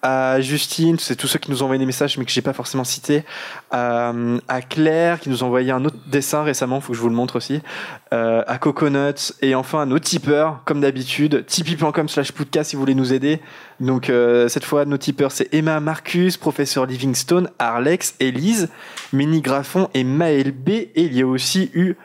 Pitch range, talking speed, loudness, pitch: 130-155 Hz, 200 wpm, -19 LUFS, 140 Hz